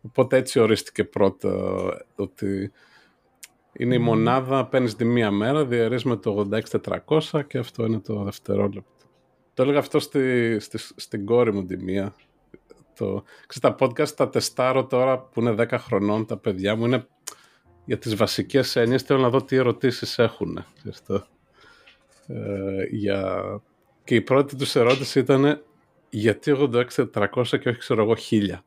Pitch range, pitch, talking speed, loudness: 105-135 Hz, 120 Hz, 150 wpm, -23 LUFS